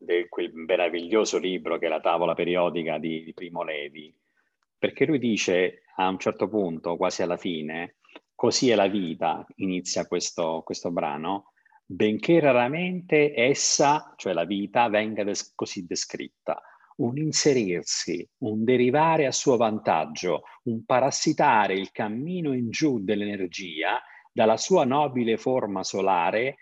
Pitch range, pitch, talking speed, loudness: 90-130 Hz, 110 Hz, 135 wpm, -25 LUFS